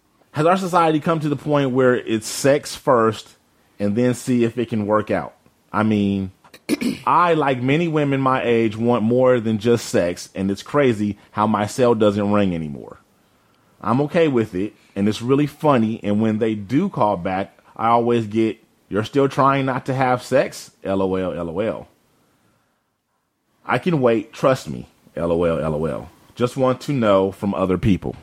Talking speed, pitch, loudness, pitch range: 170 wpm, 115 Hz, -20 LUFS, 100-135 Hz